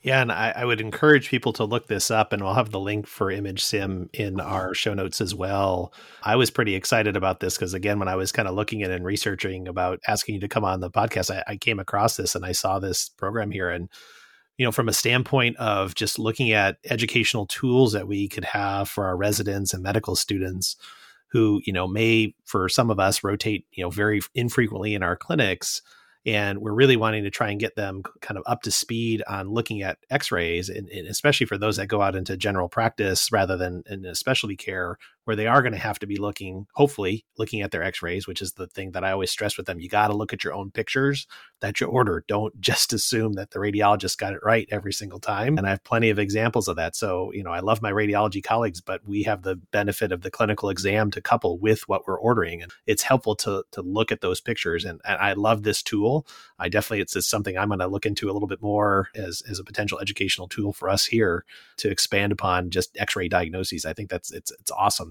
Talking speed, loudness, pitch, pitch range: 240 wpm, -24 LUFS, 105 Hz, 95-110 Hz